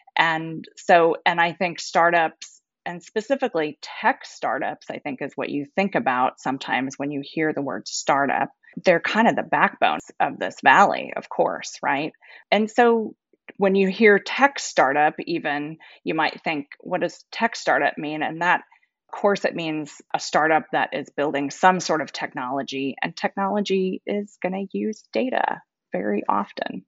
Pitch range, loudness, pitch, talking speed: 155-205 Hz, -22 LUFS, 175 Hz, 165 wpm